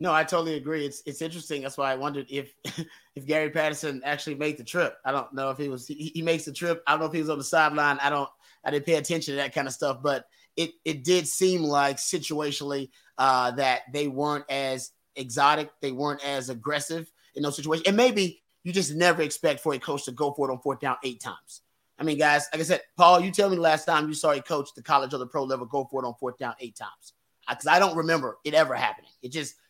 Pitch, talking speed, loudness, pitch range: 150 Hz, 260 wpm, -26 LUFS, 140-160 Hz